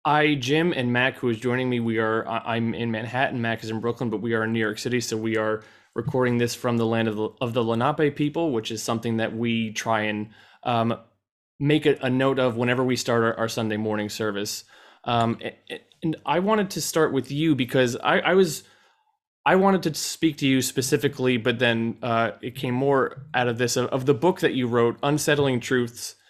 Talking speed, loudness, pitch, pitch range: 220 wpm, -24 LUFS, 125 Hz, 115-145 Hz